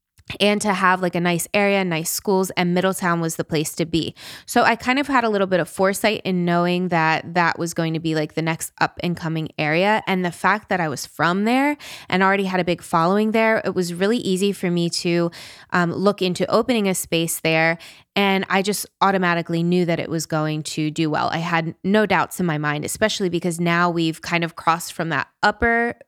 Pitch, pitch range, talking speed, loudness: 175 Hz, 165-195 Hz, 230 wpm, -20 LUFS